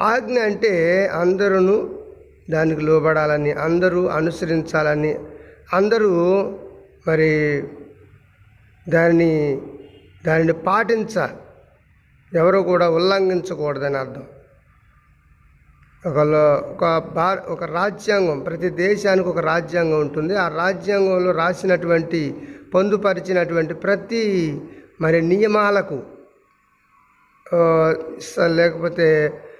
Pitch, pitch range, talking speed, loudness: 170 Hz, 155-190 Hz, 70 wpm, -19 LUFS